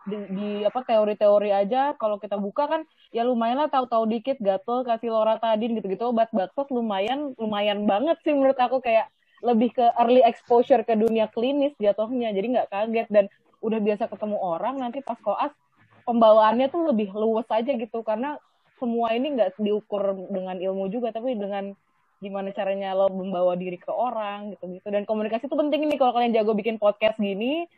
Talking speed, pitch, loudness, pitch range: 175 wpm, 220 Hz, -24 LUFS, 205-245 Hz